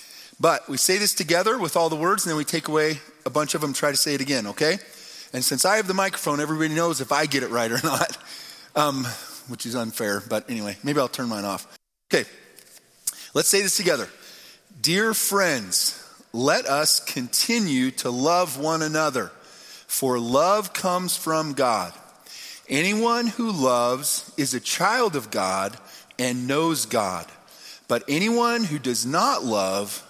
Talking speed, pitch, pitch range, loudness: 170 wpm, 155 Hz, 125-180 Hz, -23 LUFS